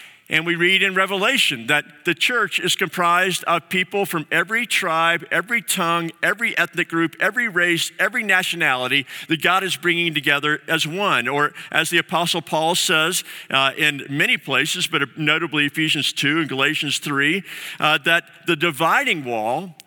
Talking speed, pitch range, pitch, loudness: 160 wpm, 155-180 Hz, 170 Hz, -19 LUFS